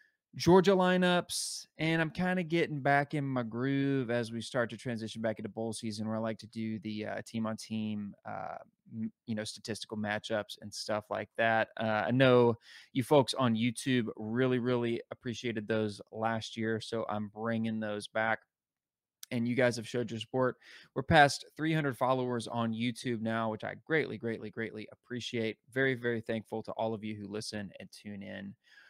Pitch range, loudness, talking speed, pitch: 110-130 Hz, -33 LUFS, 180 wpm, 115 Hz